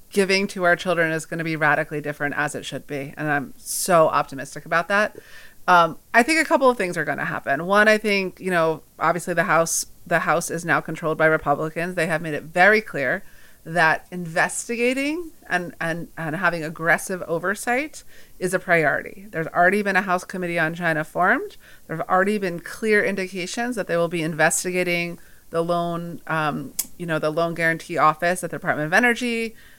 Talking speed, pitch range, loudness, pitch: 195 wpm, 160-190 Hz, -22 LUFS, 170 Hz